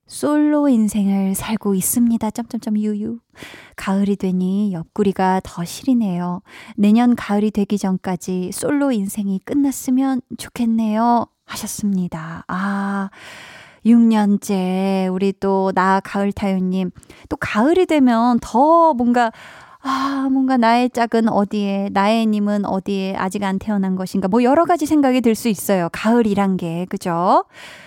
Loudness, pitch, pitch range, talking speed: -18 LUFS, 210 Hz, 195-240 Hz, 270 characters per minute